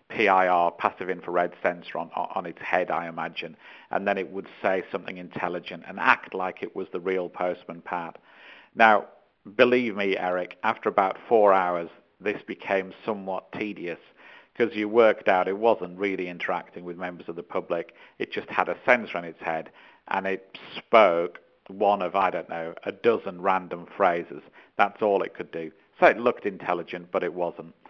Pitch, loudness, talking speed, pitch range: 90 Hz, -26 LUFS, 180 wpm, 90-95 Hz